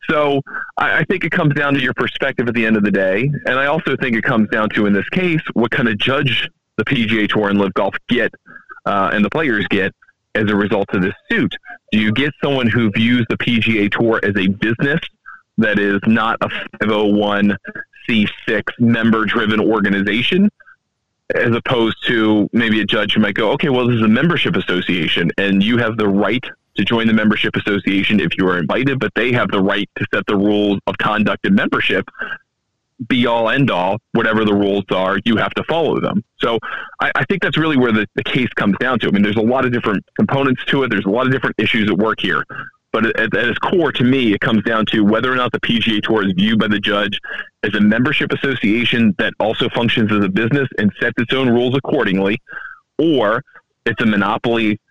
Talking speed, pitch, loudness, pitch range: 220 wpm, 115 Hz, -16 LUFS, 105-130 Hz